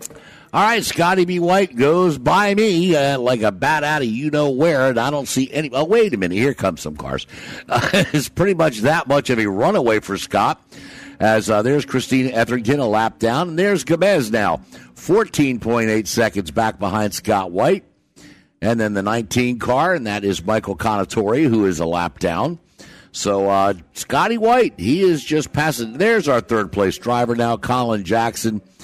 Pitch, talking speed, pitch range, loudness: 125 Hz, 185 wpm, 110-155 Hz, -18 LUFS